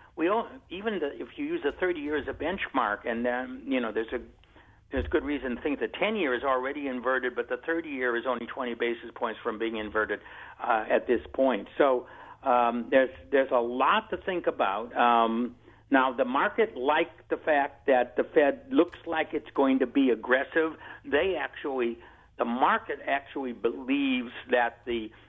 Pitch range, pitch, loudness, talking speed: 120-155 Hz, 130 Hz, -28 LUFS, 185 wpm